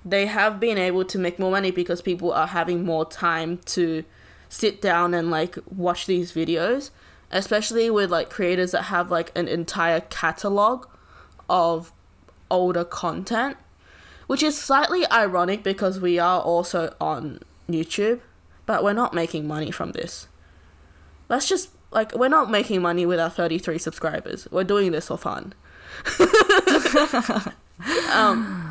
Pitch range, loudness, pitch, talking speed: 170-215 Hz, -22 LUFS, 180 Hz, 145 wpm